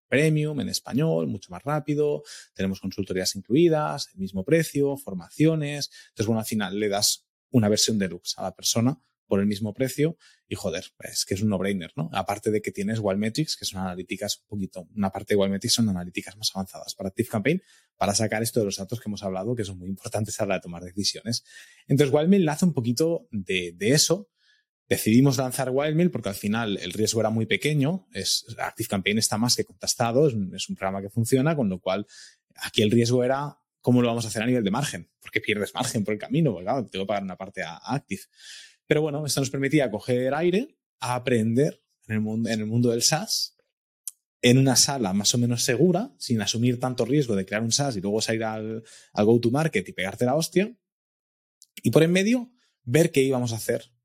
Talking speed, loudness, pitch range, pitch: 215 wpm, -25 LUFS, 100-145 Hz, 115 Hz